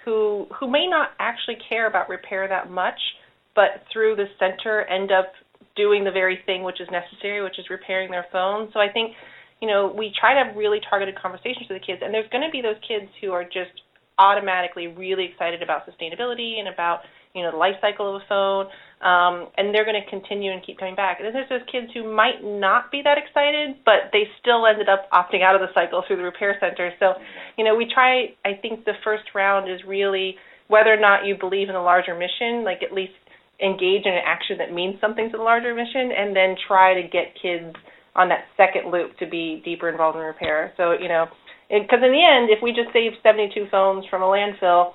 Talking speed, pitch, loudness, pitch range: 225 wpm, 195 Hz, -21 LUFS, 185-220 Hz